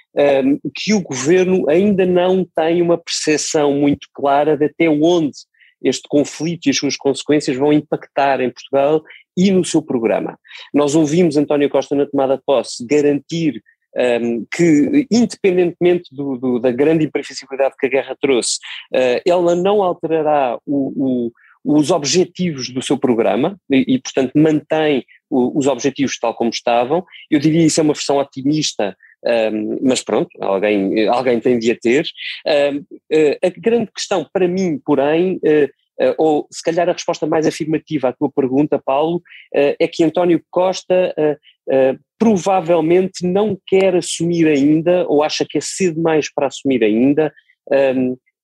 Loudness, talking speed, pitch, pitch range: -16 LUFS, 160 wpm, 150 Hz, 140-175 Hz